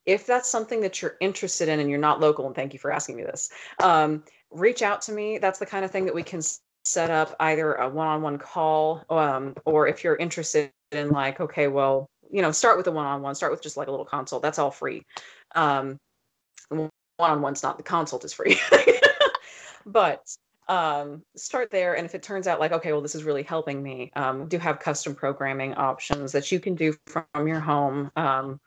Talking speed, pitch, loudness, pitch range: 220 wpm, 155 Hz, -25 LUFS, 140-175 Hz